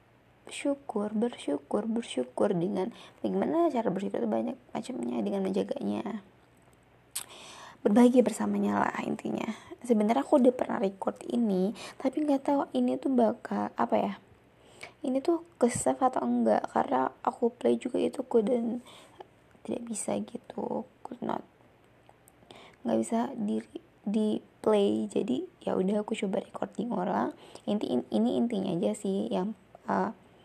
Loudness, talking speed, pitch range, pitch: -30 LUFS, 130 wpm, 200-255 Hz, 225 Hz